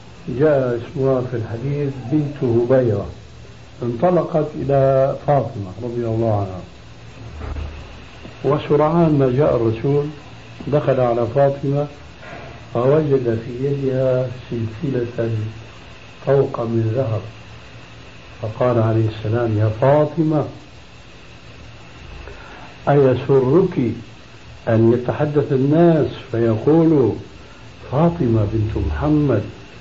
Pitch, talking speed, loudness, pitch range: 125 Hz, 80 wpm, -18 LUFS, 115-140 Hz